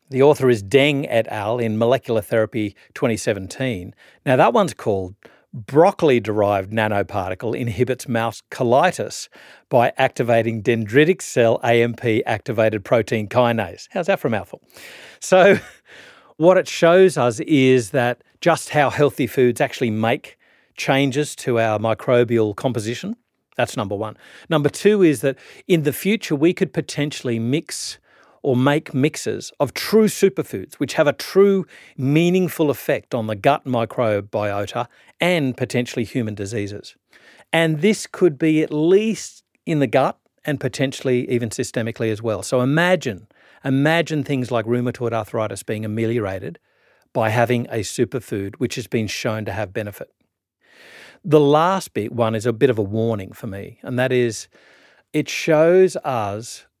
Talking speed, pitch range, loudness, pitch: 145 wpm, 115-150 Hz, -19 LUFS, 125 Hz